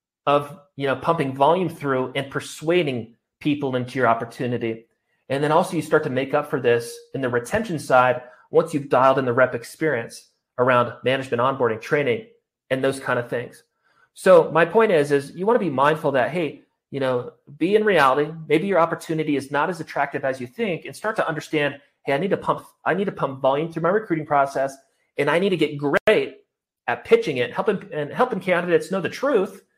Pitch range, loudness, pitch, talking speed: 135-165 Hz, -22 LUFS, 145 Hz, 210 wpm